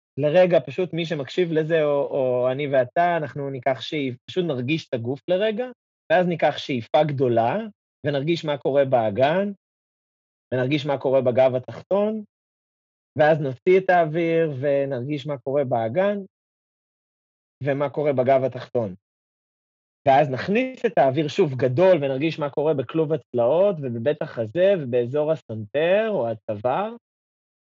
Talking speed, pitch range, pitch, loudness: 125 wpm, 130-170 Hz, 145 Hz, -22 LUFS